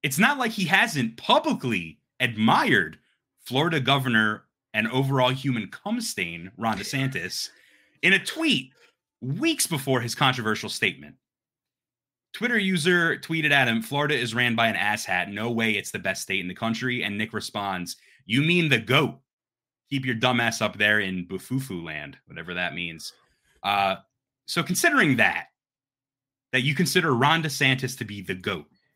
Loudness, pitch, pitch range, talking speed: -24 LUFS, 130 Hz, 110-145 Hz, 155 wpm